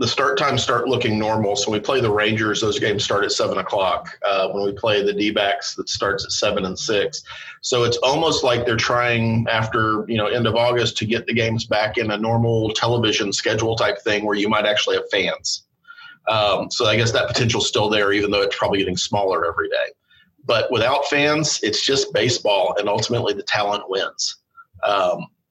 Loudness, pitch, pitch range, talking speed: -19 LUFS, 115 Hz, 110-140 Hz, 205 wpm